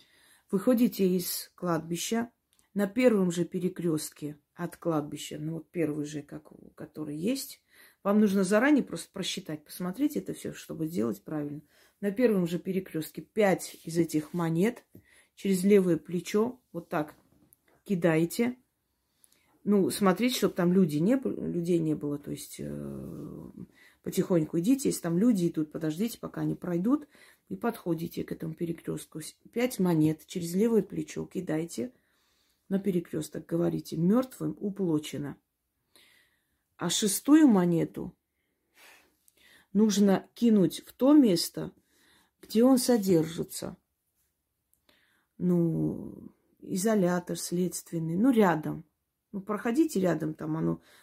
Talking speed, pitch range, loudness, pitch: 120 wpm, 160-210 Hz, -29 LUFS, 175 Hz